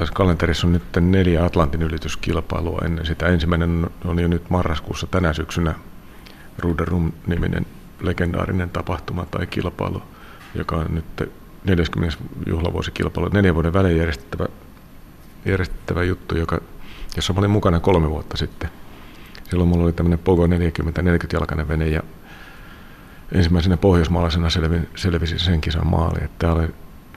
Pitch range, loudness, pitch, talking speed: 80-90 Hz, -21 LUFS, 85 Hz, 125 wpm